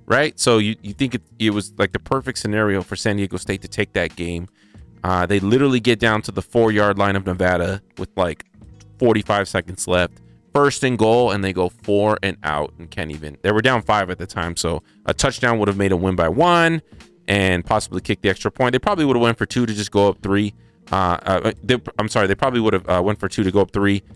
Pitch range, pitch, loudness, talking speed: 95-115 Hz, 105 Hz, -19 LUFS, 250 wpm